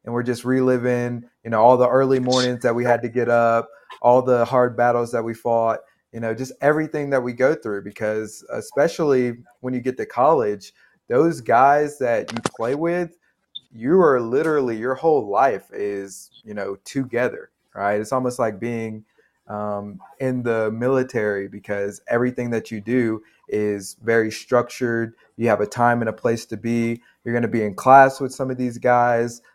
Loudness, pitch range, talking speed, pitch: -21 LUFS, 110-125 Hz, 185 wpm, 120 Hz